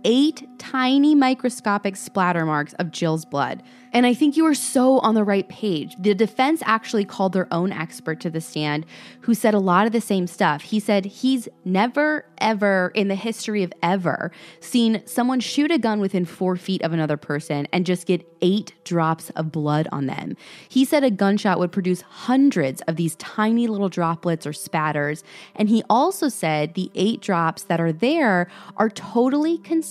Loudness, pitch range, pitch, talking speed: -21 LUFS, 170-240 Hz, 200 Hz, 185 wpm